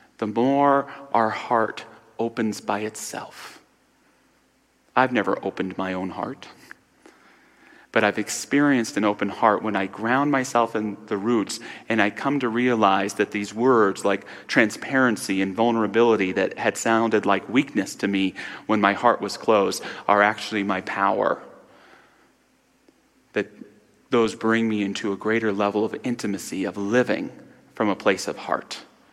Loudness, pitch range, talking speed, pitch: -23 LUFS, 100-120 Hz, 145 wpm, 110 Hz